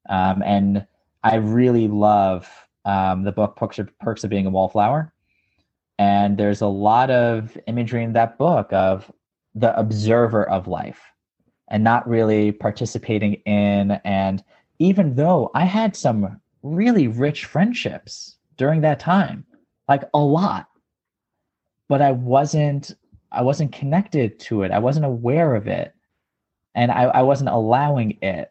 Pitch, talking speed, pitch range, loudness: 115 Hz, 145 wpm, 105-145 Hz, -20 LUFS